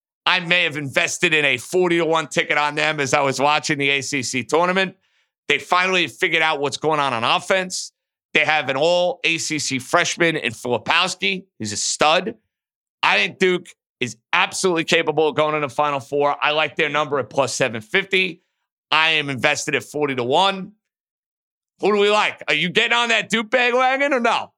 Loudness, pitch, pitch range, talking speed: -19 LUFS, 155 Hz, 145-185 Hz, 195 wpm